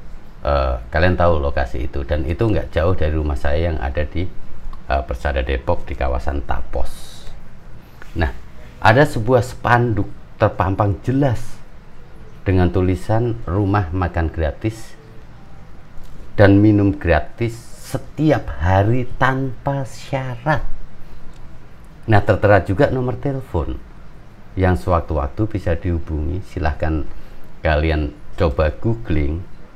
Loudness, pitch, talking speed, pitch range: -19 LUFS, 95 Hz, 105 wpm, 80-115 Hz